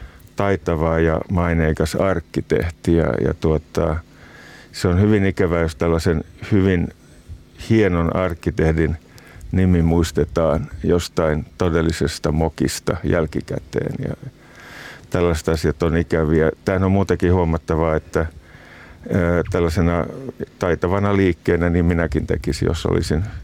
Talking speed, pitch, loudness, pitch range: 105 wpm, 85 Hz, -20 LUFS, 80-90 Hz